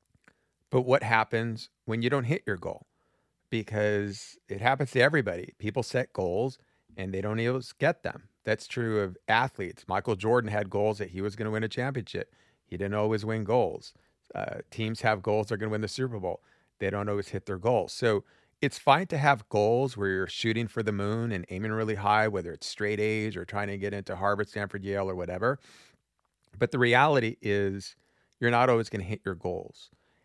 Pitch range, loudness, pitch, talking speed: 100-115 Hz, -29 LUFS, 110 Hz, 205 wpm